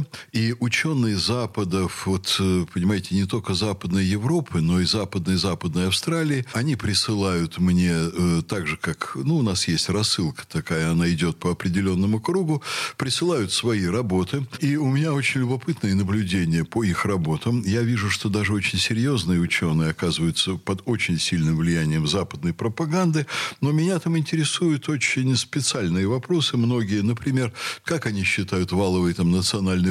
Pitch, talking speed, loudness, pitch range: 105 Hz, 145 wpm, -23 LUFS, 90-130 Hz